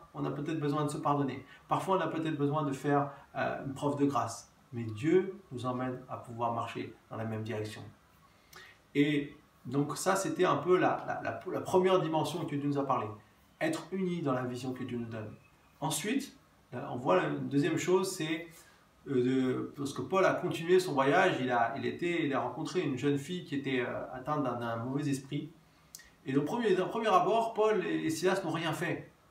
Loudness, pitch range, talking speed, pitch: -32 LUFS, 130-170 Hz, 200 wpm, 145 Hz